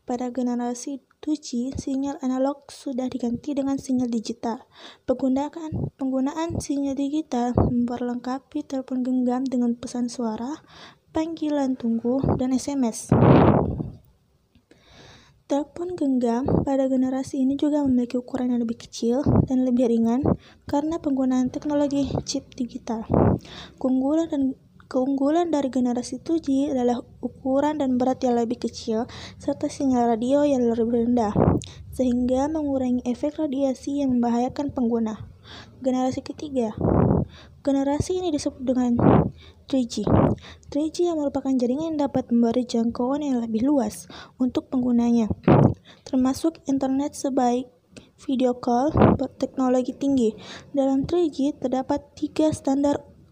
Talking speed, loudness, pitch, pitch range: 115 wpm, -24 LUFS, 260 Hz, 245-285 Hz